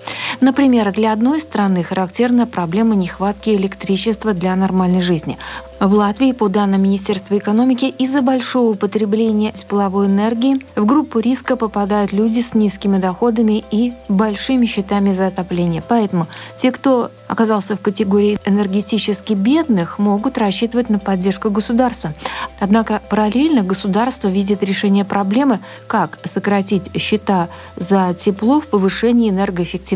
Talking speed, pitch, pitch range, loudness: 125 wpm, 210 Hz, 195-230 Hz, -16 LUFS